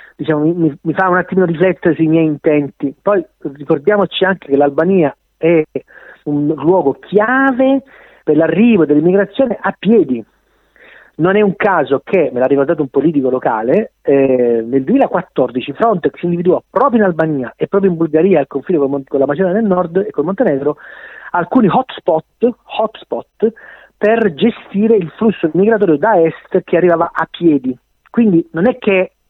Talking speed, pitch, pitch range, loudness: 160 wpm, 175 Hz, 150-205 Hz, -14 LUFS